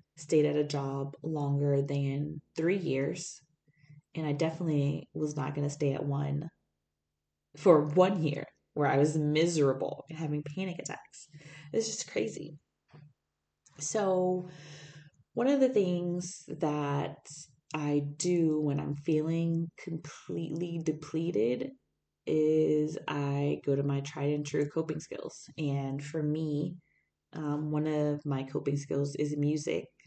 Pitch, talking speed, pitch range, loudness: 150 Hz, 130 wpm, 145-160 Hz, -32 LUFS